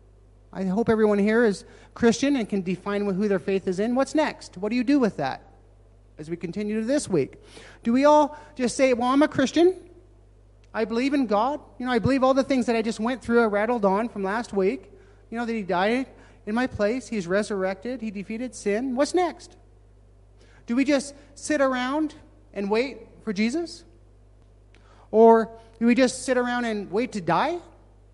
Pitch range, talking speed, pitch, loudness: 190-255 Hz, 200 wpm, 225 Hz, -24 LUFS